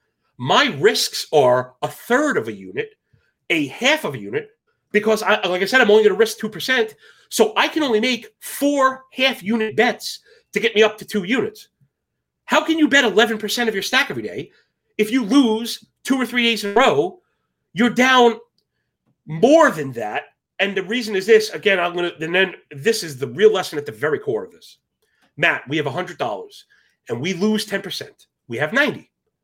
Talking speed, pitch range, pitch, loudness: 205 wpm, 200-260 Hz, 225 Hz, -19 LUFS